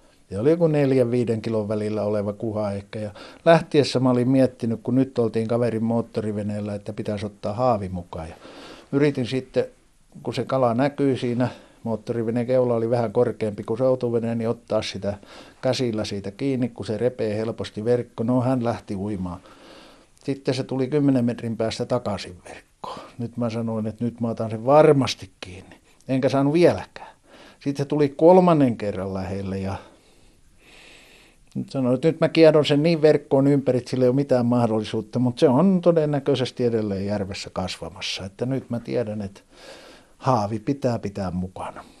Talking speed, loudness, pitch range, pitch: 165 wpm, -23 LUFS, 105-130 Hz, 120 Hz